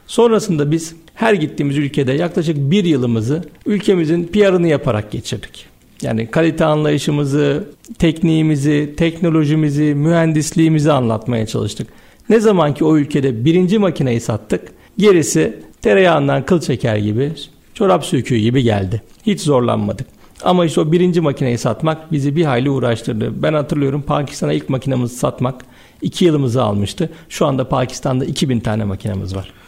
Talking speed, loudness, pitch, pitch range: 130 wpm, -16 LUFS, 150 Hz, 130-165 Hz